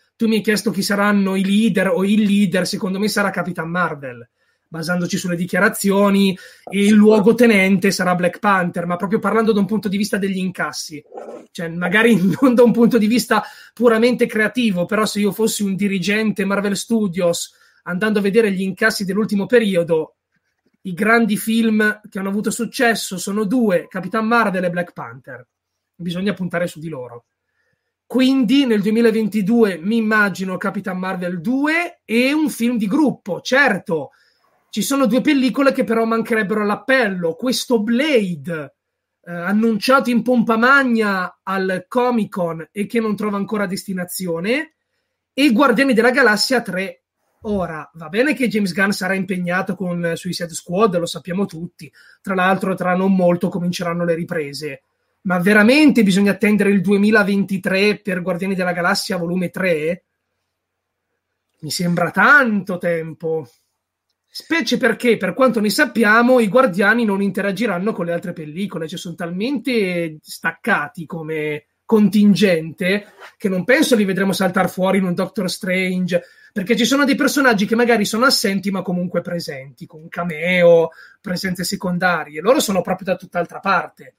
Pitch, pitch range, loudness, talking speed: 200 Hz, 175-225 Hz, -17 LUFS, 150 wpm